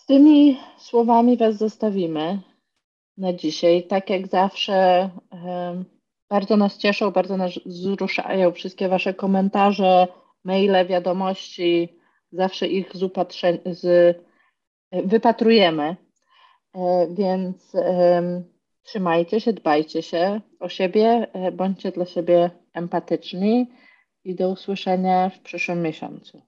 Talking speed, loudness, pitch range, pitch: 100 wpm, -21 LUFS, 180-205 Hz, 185 Hz